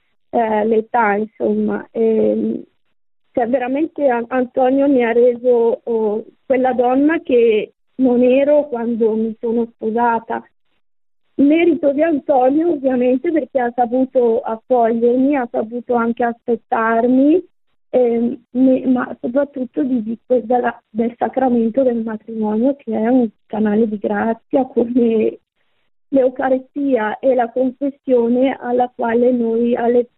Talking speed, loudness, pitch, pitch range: 115 wpm, -17 LUFS, 245 Hz, 230-260 Hz